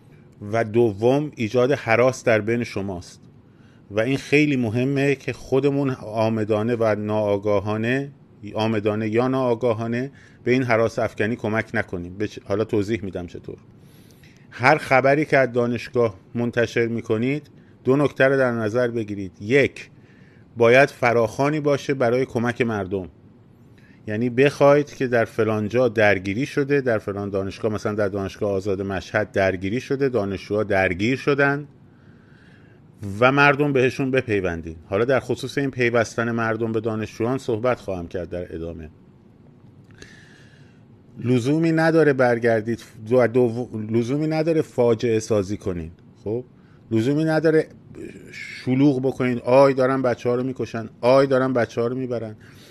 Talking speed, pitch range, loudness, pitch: 130 wpm, 110-130 Hz, -21 LUFS, 120 Hz